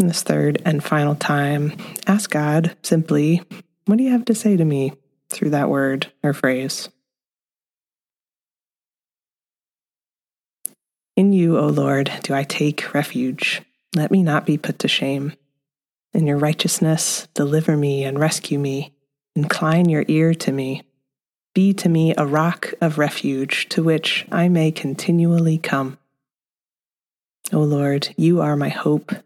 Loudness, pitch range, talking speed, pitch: -19 LUFS, 140-170 Hz, 140 wpm, 155 Hz